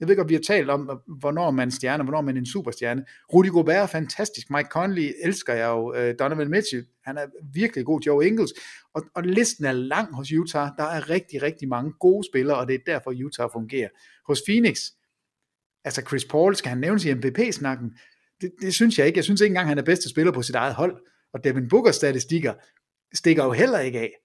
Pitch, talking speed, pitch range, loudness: 150 Hz, 220 wpm, 130-180 Hz, -23 LUFS